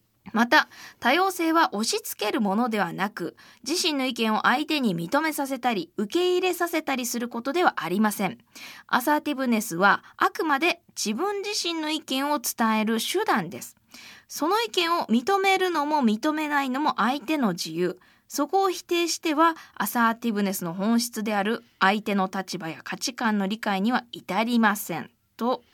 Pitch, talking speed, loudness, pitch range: 250 Hz, 330 characters per minute, -25 LUFS, 210-320 Hz